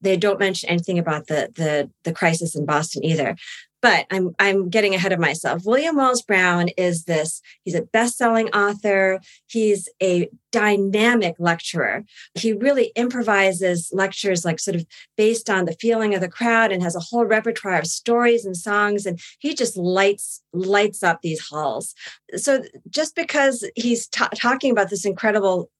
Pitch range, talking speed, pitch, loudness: 175-225 Hz, 165 wpm, 195 Hz, -20 LUFS